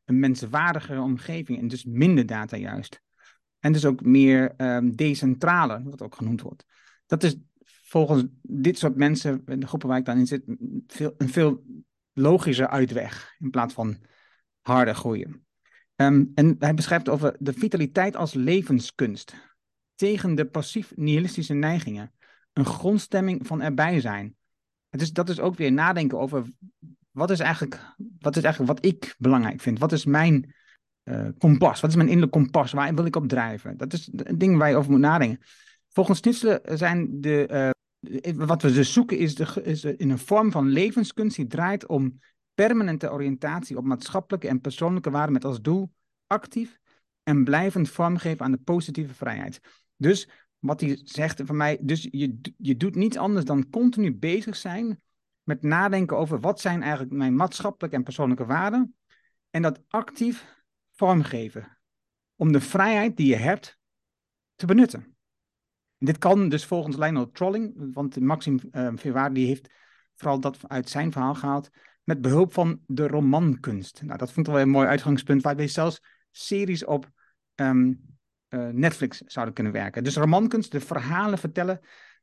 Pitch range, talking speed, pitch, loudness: 135-175 Hz, 165 wpm, 150 Hz, -24 LUFS